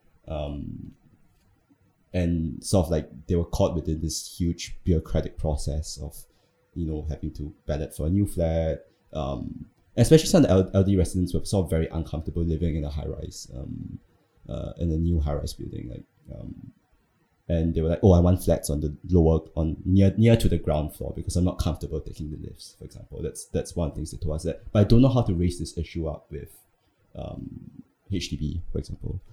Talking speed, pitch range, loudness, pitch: 205 wpm, 75-90 Hz, -26 LUFS, 85 Hz